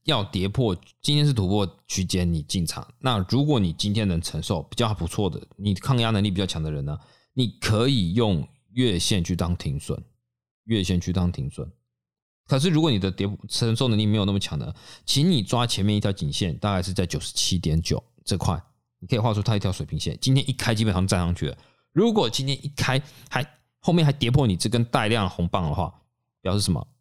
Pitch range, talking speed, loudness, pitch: 95-125 Hz, 305 characters per minute, -24 LUFS, 105 Hz